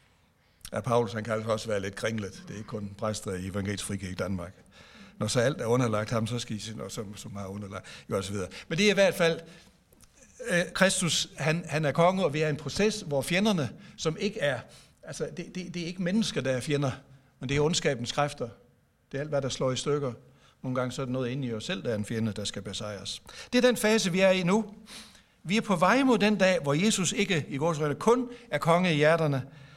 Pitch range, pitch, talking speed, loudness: 110-180 Hz, 140 Hz, 245 wpm, -28 LUFS